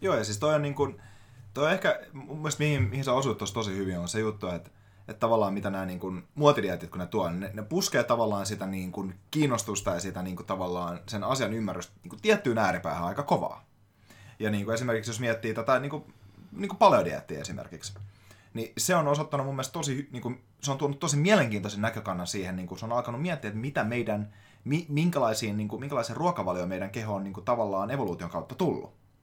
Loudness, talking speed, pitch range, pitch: -29 LUFS, 200 wpm, 100-135 Hz, 110 Hz